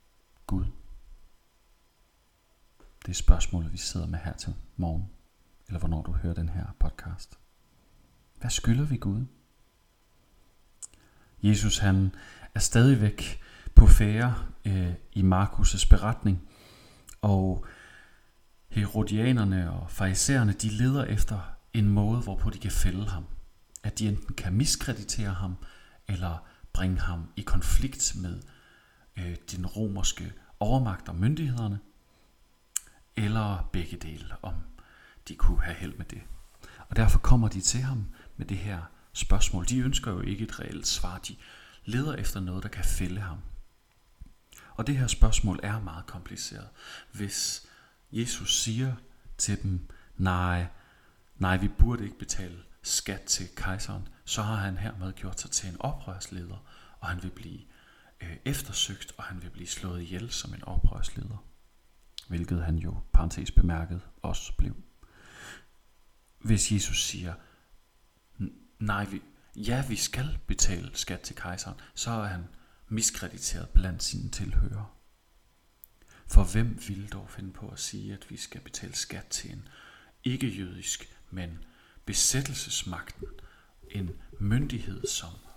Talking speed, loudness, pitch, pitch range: 130 wpm, -30 LUFS, 100 Hz, 90-110 Hz